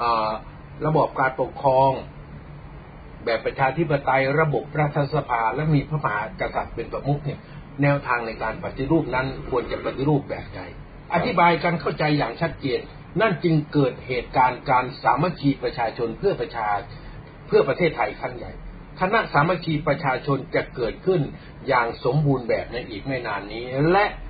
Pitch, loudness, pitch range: 145 Hz, -23 LUFS, 130-160 Hz